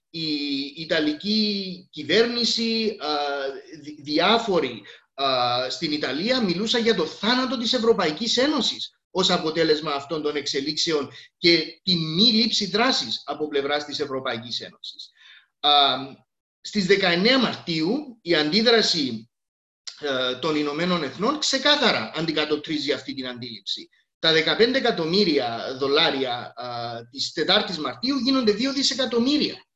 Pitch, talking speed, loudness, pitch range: 165 Hz, 105 wpm, -22 LUFS, 145-230 Hz